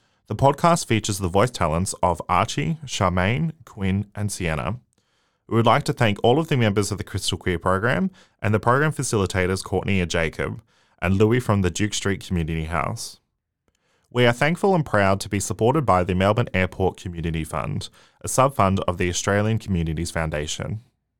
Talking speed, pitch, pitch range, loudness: 180 wpm, 105 Hz, 90-120 Hz, -22 LUFS